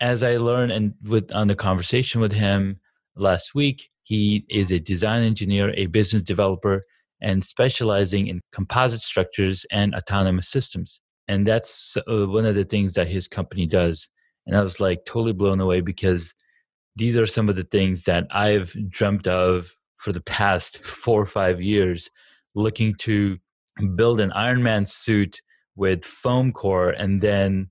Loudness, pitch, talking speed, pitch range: -22 LUFS, 100 Hz, 160 wpm, 95-110 Hz